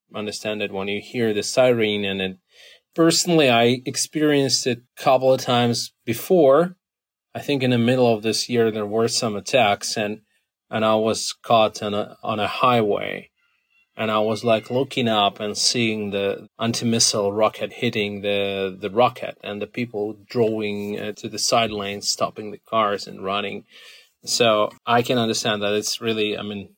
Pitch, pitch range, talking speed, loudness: 110 Hz, 105-120 Hz, 175 wpm, -21 LUFS